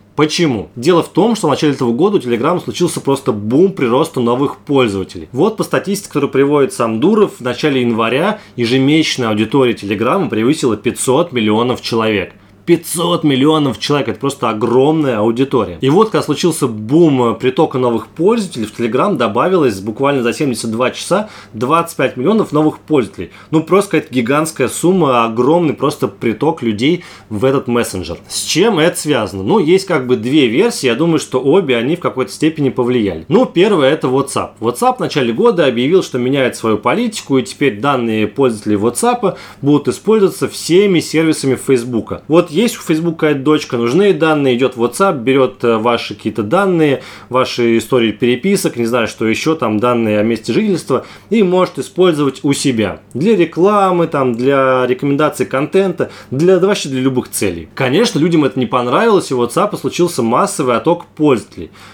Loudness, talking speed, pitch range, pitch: -14 LUFS, 165 wpm, 120-160 Hz, 135 Hz